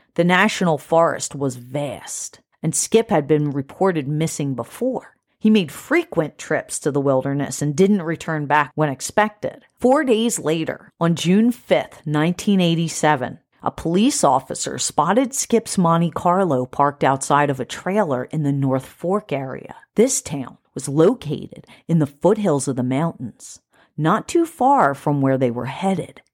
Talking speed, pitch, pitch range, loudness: 155 wpm, 155 Hz, 140-195 Hz, -20 LUFS